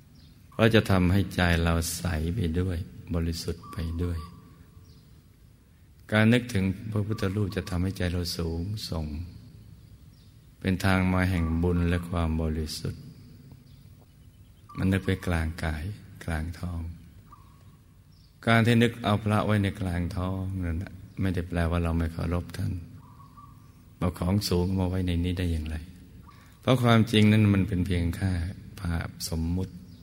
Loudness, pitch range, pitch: -27 LUFS, 85-105 Hz, 90 Hz